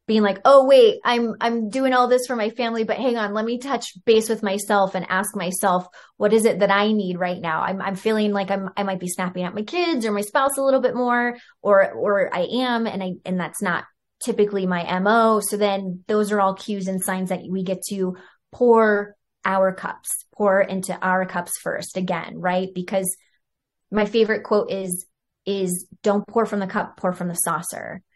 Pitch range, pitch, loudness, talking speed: 185-225 Hz, 200 Hz, -21 LUFS, 215 wpm